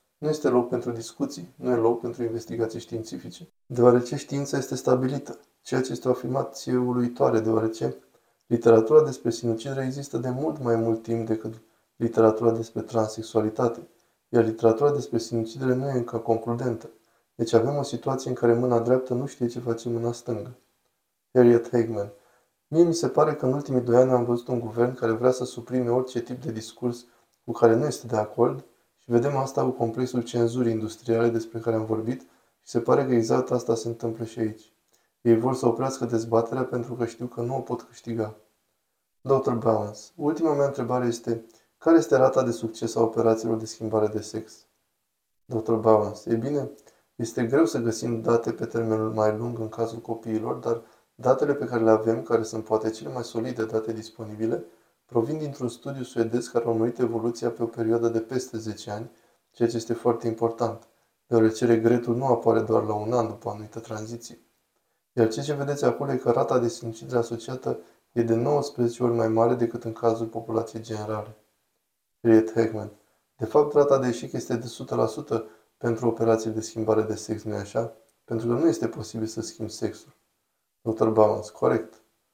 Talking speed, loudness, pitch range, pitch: 180 wpm, -25 LUFS, 110-120 Hz, 115 Hz